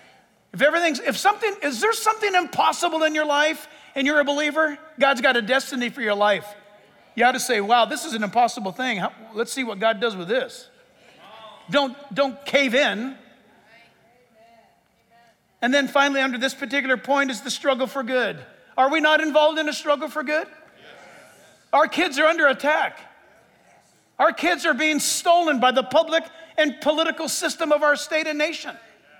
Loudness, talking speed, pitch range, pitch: -21 LUFS, 175 wpm, 250-310 Hz, 285 Hz